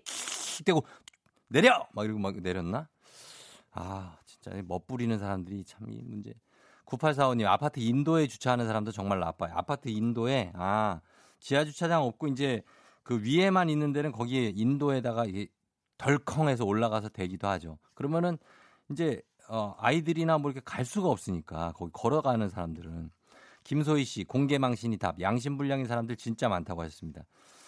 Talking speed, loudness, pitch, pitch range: 330 characters per minute, -30 LUFS, 115 Hz, 100-140 Hz